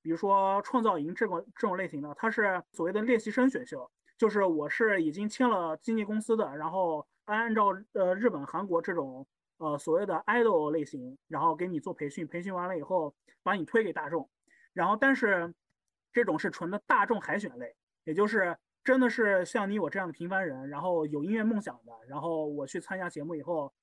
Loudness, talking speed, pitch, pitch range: -30 LUFS, 310 characters per minute, 185 Hz, 160-215 Hz